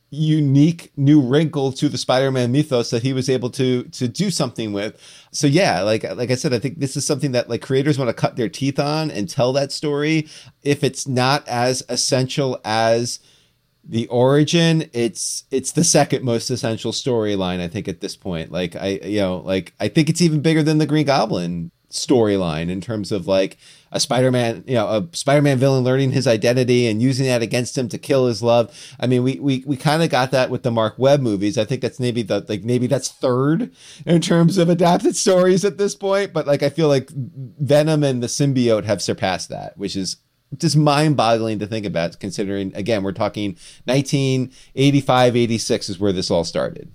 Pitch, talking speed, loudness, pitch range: 130 Hz, 205 wpm, -19 LUFS, 115-145 Hz